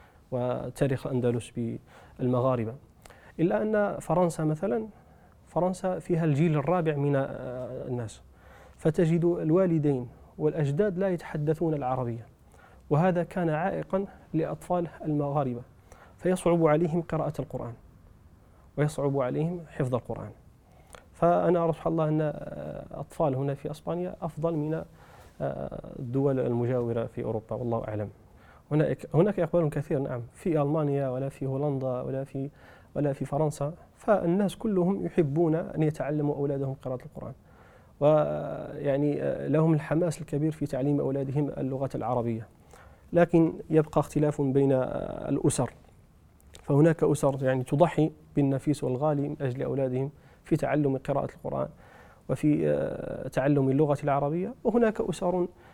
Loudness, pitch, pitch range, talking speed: -28 LUFS, 145 Hz, 130-165 Hz, 110 wpm